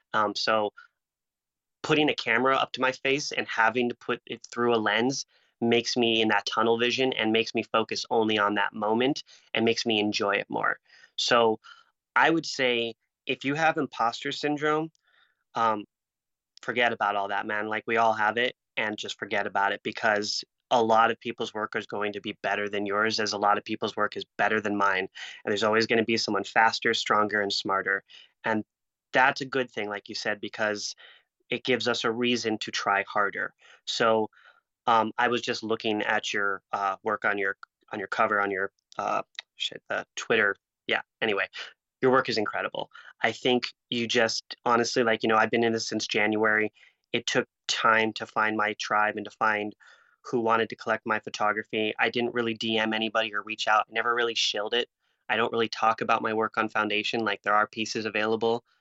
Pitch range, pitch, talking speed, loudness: 105-120 Hz, 110 Hz, 200 wpm, -26 LUFS